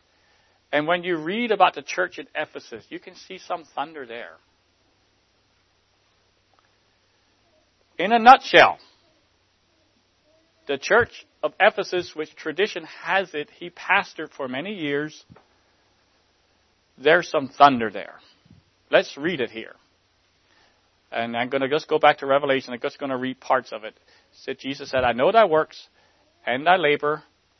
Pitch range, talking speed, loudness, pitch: 100-155 Hz, 145 wpm, -22 LUFS, 140 Hz